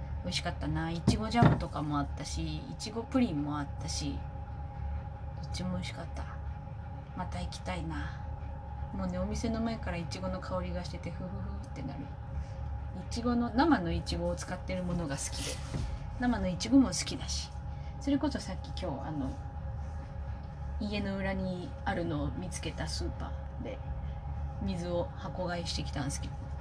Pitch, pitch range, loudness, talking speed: 85 Hz, 75-95 Hz, -35 LUFS, 330 characters per minute